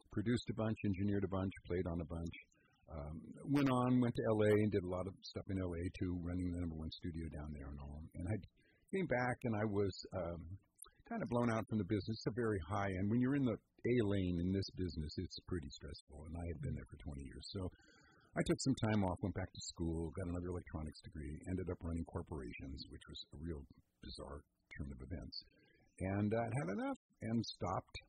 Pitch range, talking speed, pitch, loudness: 85-110 Hz, 225 wpm, 95 Hz, -41 LUFS